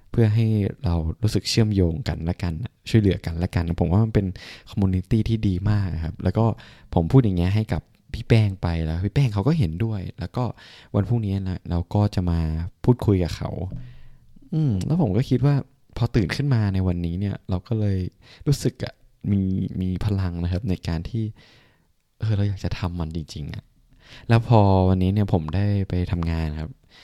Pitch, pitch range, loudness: 100 Hz, 90-115 Hz, -23 LUFS